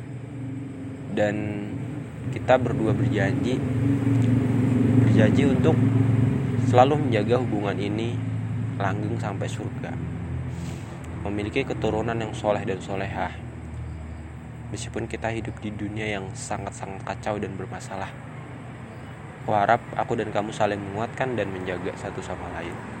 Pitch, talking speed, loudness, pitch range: 120 Hz, 105 wpm, -25 LUFS, 105-130 Hz